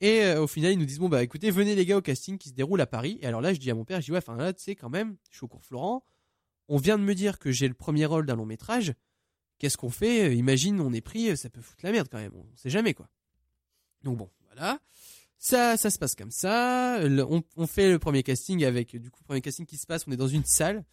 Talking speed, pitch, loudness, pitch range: 285 wpm, 155 Hz, -27 LUFS, 125-195 Hz